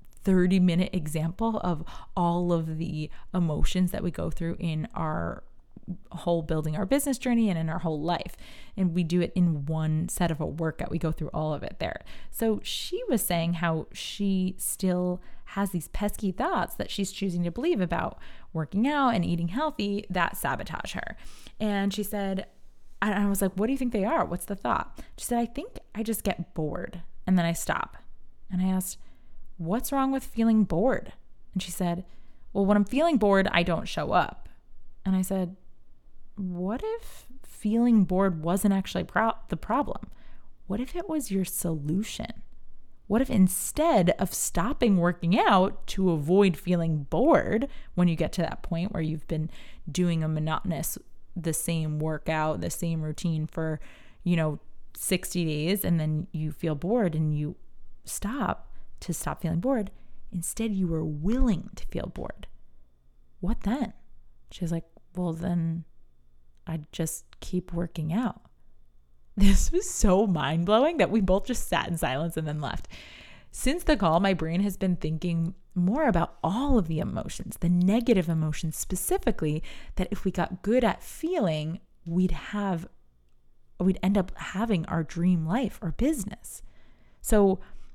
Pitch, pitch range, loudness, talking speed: 180 Hz, 160-200 Hz, -28 LUFS, 170 wpm